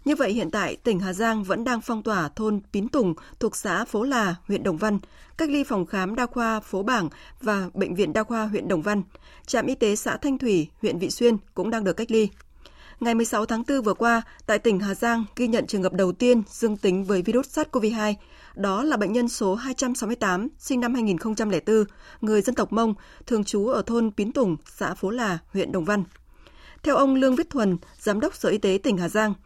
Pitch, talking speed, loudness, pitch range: 220 Hz, 225 wpm, -24 LUFS, 200-240 Hz